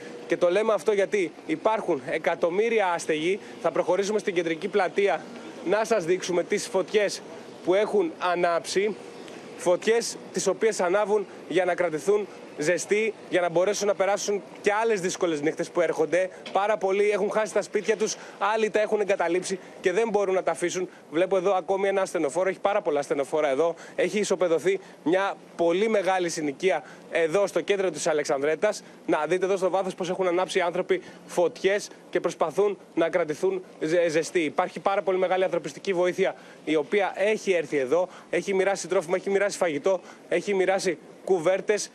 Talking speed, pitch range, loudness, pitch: 165 wpm, 175-205 Hz, -26 LUFS, 190 Hz